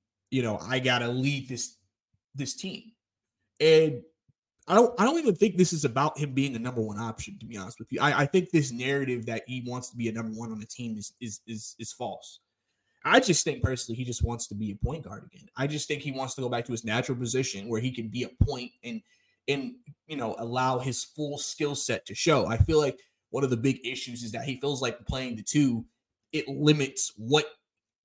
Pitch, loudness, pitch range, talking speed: 130 Hz, -28 LUFS, 115-145 Hz, 235 wpm